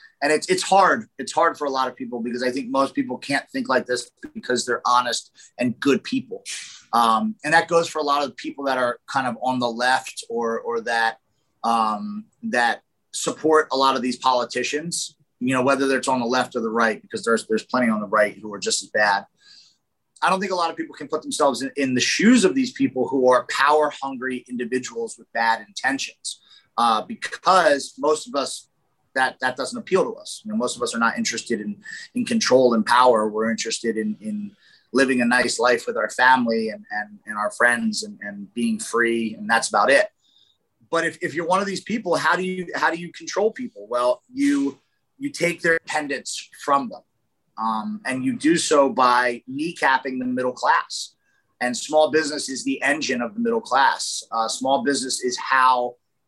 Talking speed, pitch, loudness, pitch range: 210 wpm, 135 Hz, -22 LUFS, 120-175 Hz